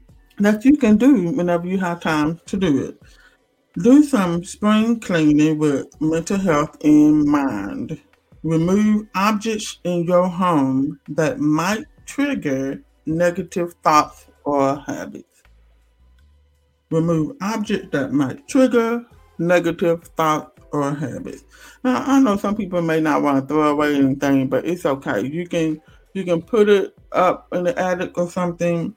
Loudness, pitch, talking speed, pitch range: -19 LUFS, 175 Hz, 140 wpm, 150-215 Hz